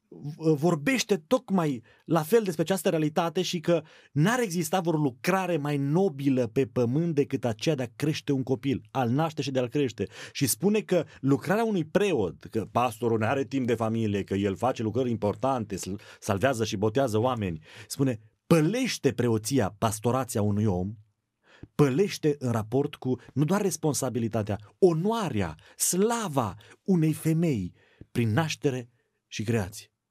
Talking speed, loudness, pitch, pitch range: 145 wpm, -27 LUFS, 135 Hz, 115-165 Hz